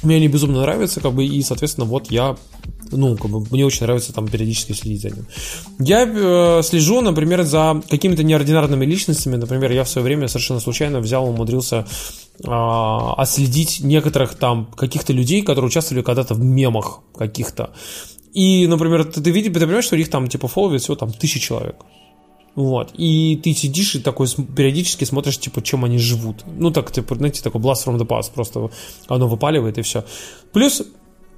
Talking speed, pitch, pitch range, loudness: 175 wpm, 135 Hz, 120-155 Hz, -18 LUFS